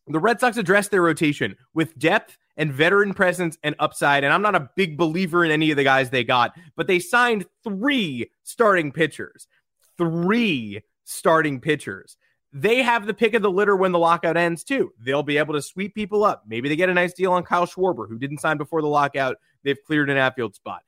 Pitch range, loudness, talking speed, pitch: 145-195 Hz, -21 LUFS, 215 wpm, 165 Hz